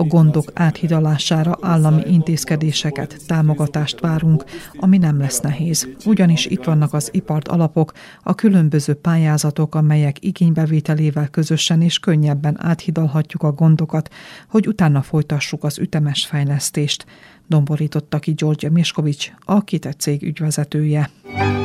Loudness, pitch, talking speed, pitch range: -17 LUFS, 155 Hz, 115 wpm, 150-165 Hz